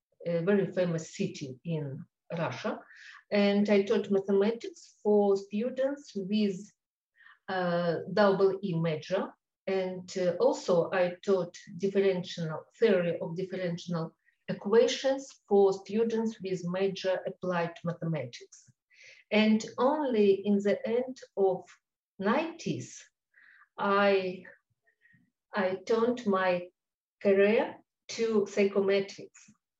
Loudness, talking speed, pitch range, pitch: -30 LUFS, 95 wpm, 185-215 Hz, 195 Hz